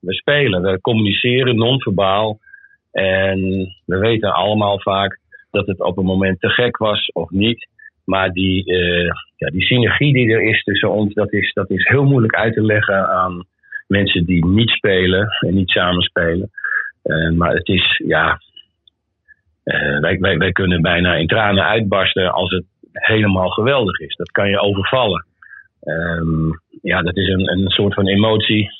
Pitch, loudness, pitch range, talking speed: 95 Hz, -16 LUFS, 90-110 Hz, 170 wpm